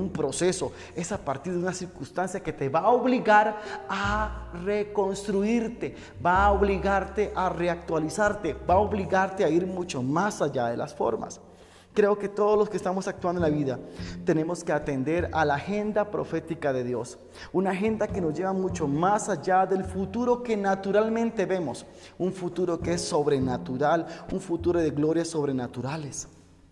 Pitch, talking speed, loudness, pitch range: 180 Hz, 165 wpm, -27 LUFS, 155-200 Hz